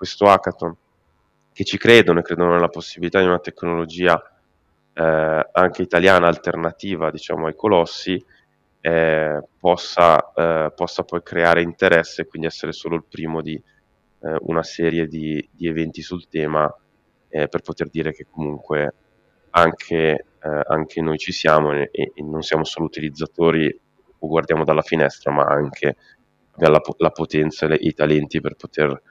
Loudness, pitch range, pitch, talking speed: -19 LUFS, 80-85 Hz, 80 Hz, 155 wpm